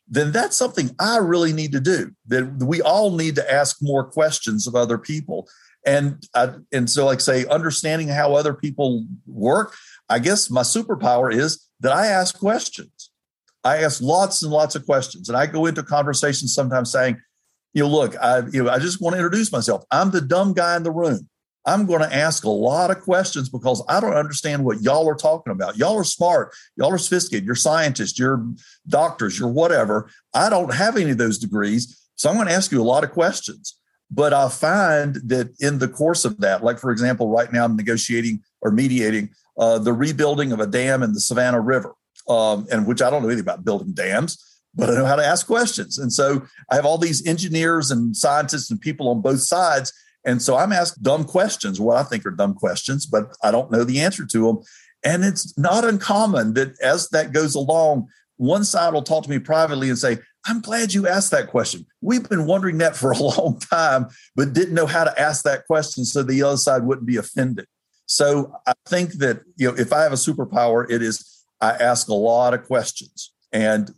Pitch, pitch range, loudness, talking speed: 145 Hz, 125-170 Hz, -20 LUFS, 215 wpm